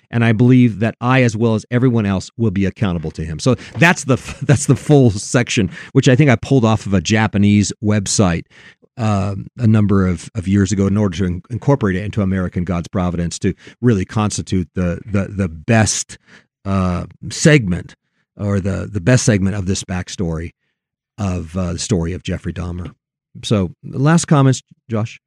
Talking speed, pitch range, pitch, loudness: 185 wpm, 95-120 Hz, 105 Hz, -17 LUFS